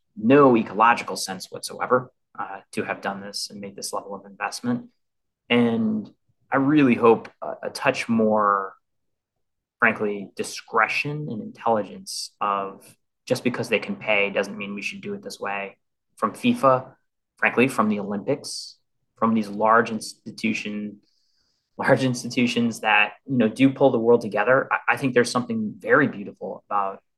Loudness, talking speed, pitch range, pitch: -23 LUFS, 150 wpm, 105-145 Hz, 120 Hz